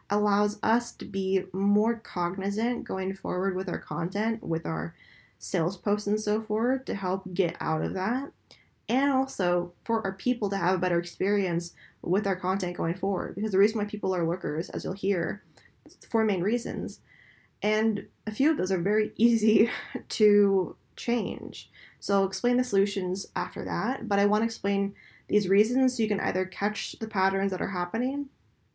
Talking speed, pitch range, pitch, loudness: 180 wpm, 185-220 Hz, 200 Hz, -28 LUFS